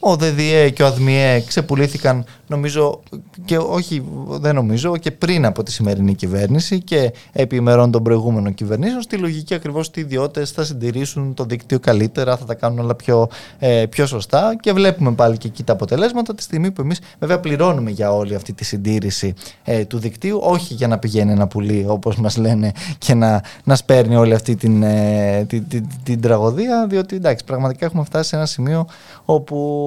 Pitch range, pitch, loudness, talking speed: 115-155 Hz, 130 Hz, -17 LUFS, 185 wpm